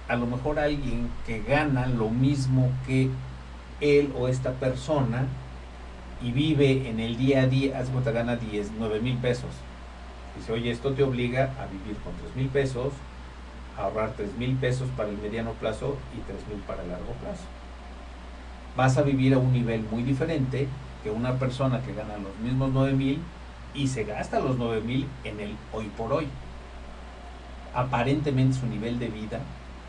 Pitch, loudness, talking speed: 120 Hz, -28 LUFS, 175 wpm